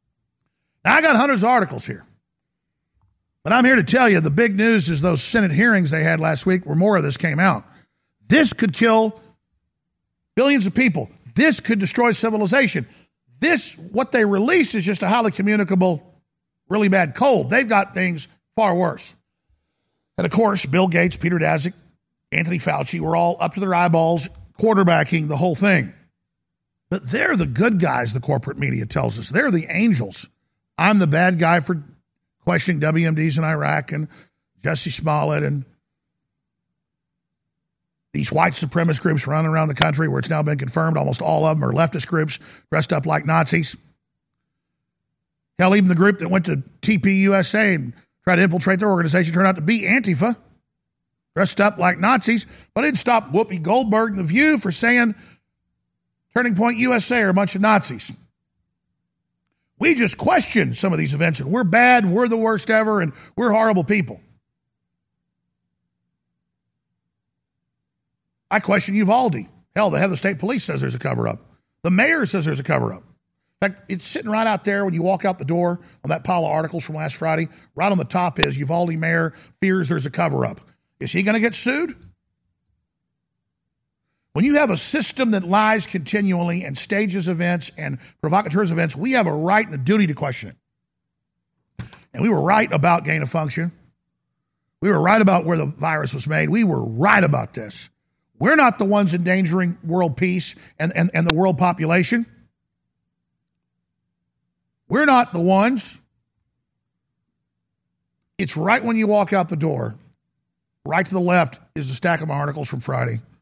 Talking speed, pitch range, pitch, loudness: 175 wpm, 155-210 Hz, 180 Hz, -19 LUFS